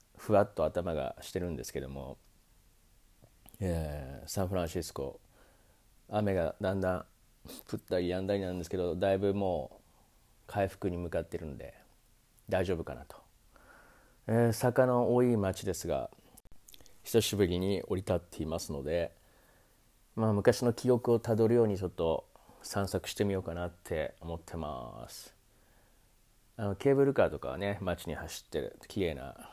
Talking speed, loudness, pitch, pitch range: 295 characters per minute, -33 LUFS, 95 Hz, 85-110 Hz